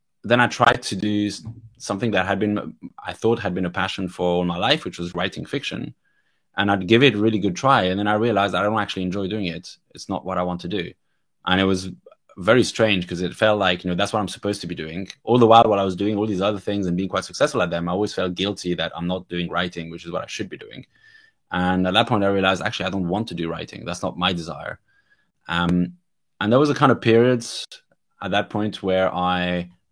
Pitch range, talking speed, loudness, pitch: 90-105 Hz, 260 wpm, -21 LUFS, 95 Hz